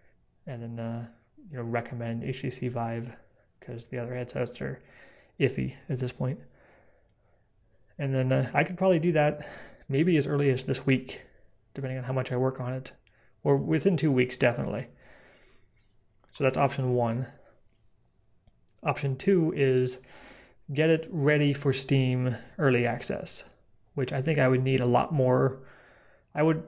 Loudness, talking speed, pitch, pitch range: -28 LUFS, 155 wpm, 130 Hz, 120-140 Hz